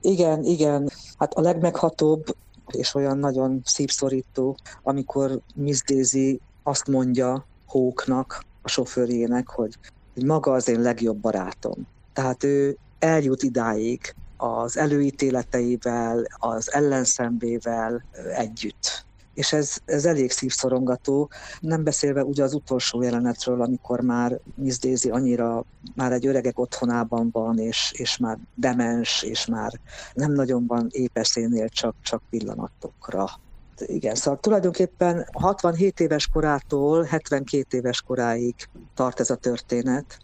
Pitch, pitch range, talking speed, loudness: 130 Hz, 120-140 Hz, 120 wpm, -24 LUFS